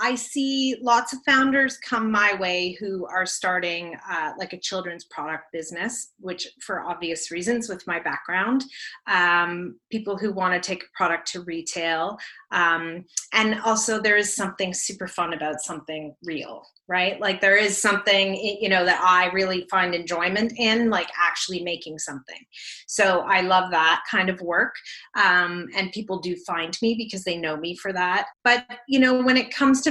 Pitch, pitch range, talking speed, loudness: 185 Hz, 175-220 Hz, 175 wpm, -23 LUFS